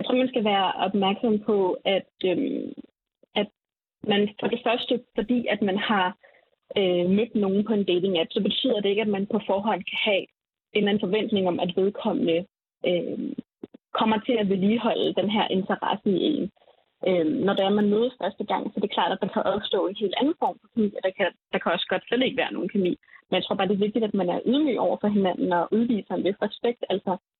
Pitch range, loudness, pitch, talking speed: 190-230 Hz, -25 LUFS, 210 Hz, 230 wpm